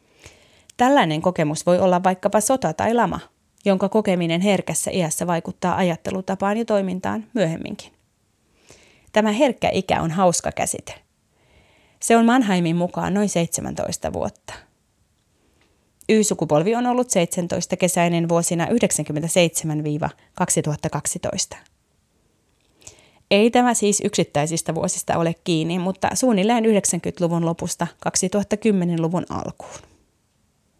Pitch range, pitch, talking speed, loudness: 165-205 Hz, 180 Hz, 95 wpm, -21 LUFS